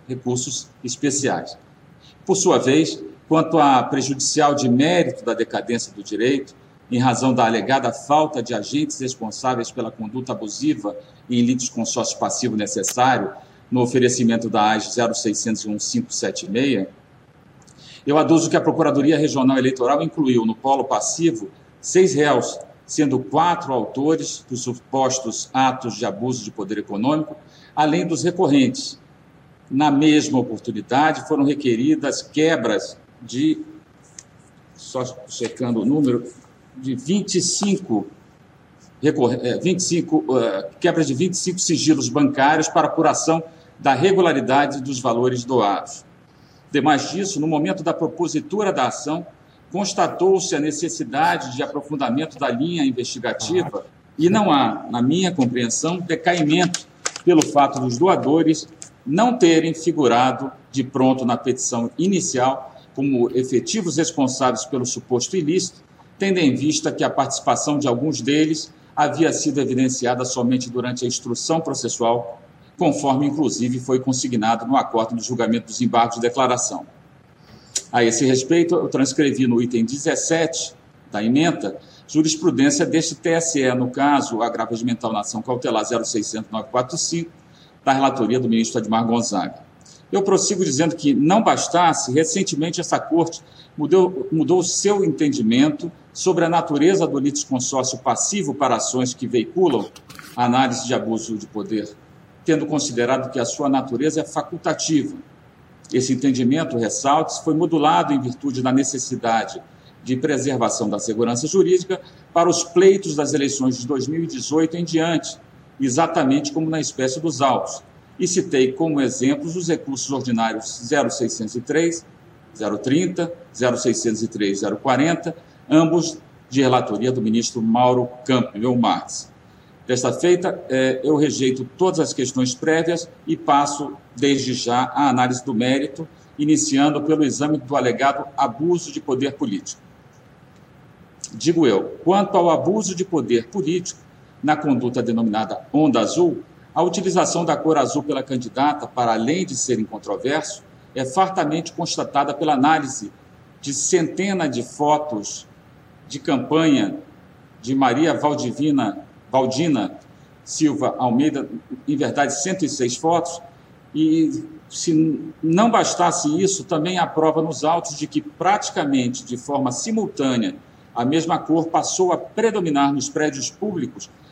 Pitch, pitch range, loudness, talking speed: 145 Hz, 125-165 Hz, -20 LUFS, 125 wpm